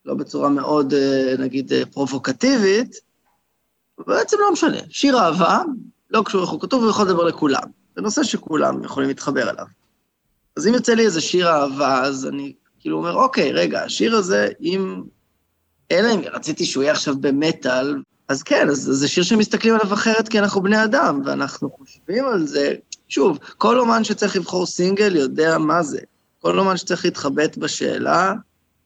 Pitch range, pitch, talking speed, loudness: 140-220 Hz, 175 Hz, 160 wpm, -19 LUFS